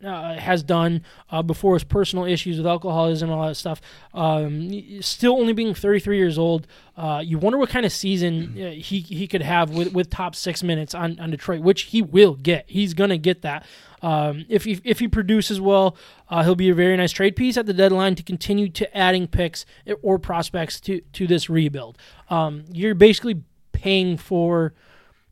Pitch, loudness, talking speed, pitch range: 180 Hz, -21 LUFS, 195 wpm, 165-195 Hz